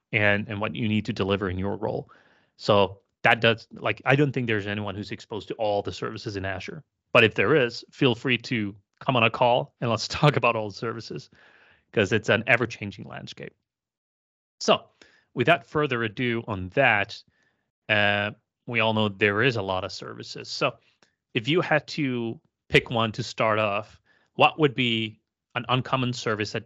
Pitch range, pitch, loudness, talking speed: 105-125 Hz, 115 Hz, -25 LUFS, 185 wpm